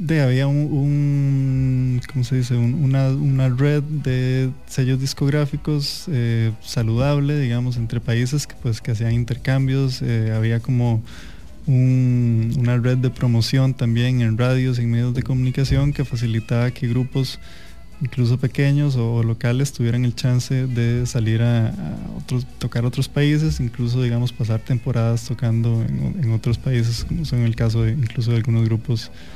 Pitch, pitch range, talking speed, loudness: 125 Hz, 115-135 Hz, 155 wpm, -20 LUFS